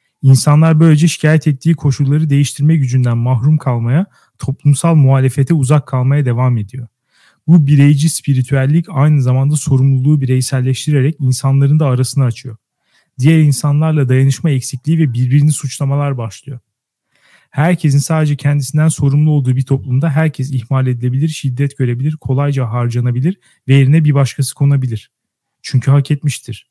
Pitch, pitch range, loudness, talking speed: 140 Hz, 130-150 Hz, -13 LUFS, 125 wpm